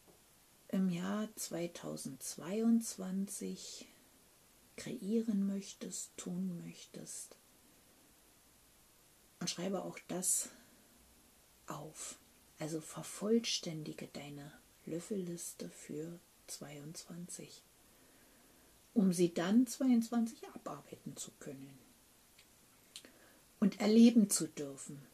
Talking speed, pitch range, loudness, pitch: 70 wpm, 160-215 Hz, -37 LUFS, 185 Hz